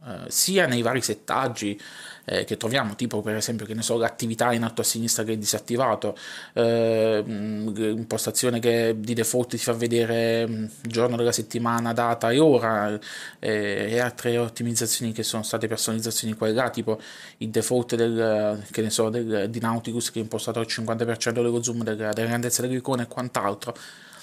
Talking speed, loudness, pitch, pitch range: 170 wpm, -25 LUFS, 115 Hz, 110-120 Hz